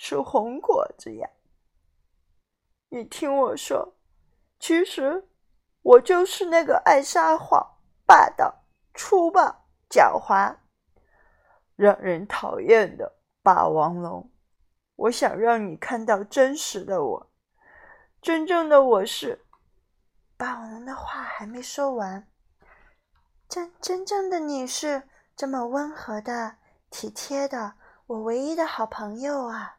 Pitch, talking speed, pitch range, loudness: 275 Hz, 160 characters per minute, 225-350 Hz, -22 LUFS